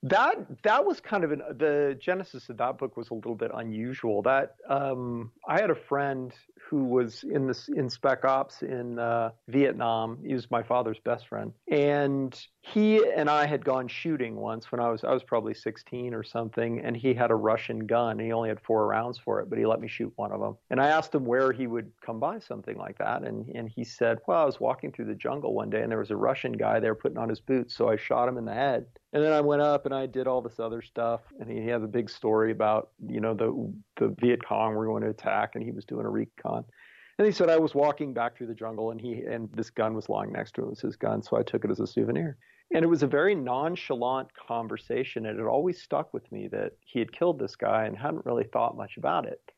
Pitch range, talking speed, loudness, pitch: 115-145 Hz, 260 wpm, -29 LUFS, 125 Hz